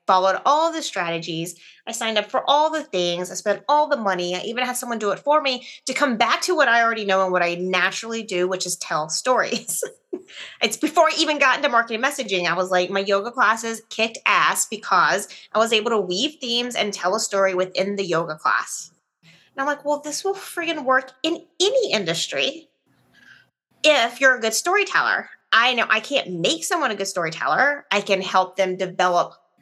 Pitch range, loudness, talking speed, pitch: 185-285 Hz, -21 LUFS, 205 wpm, 225 Hz